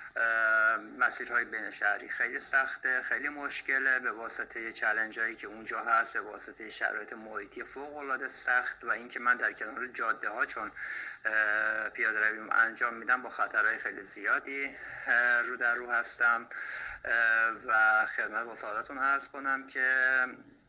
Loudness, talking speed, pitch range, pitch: -30 LUFS, 135 wpm, 115-135 Hz, 130 Hz